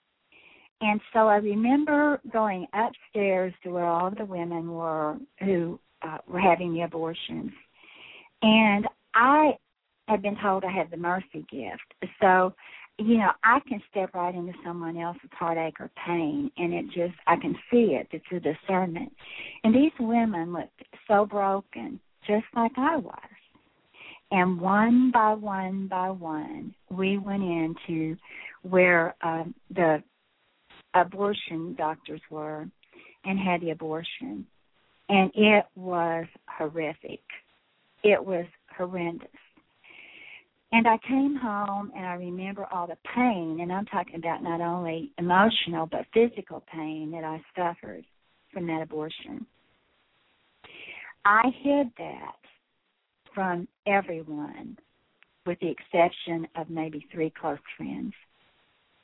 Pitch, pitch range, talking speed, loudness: 185 Hz, 165-215 Hz, 125 wpm, -26 LUFS